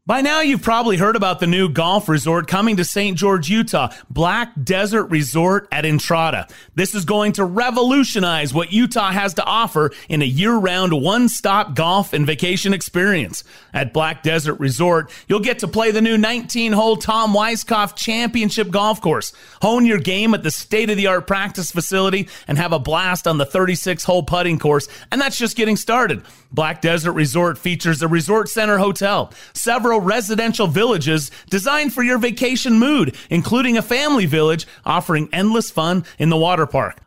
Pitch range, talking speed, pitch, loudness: 165-220 Hz, 165 wpm, 195 Hz, -17 LUFS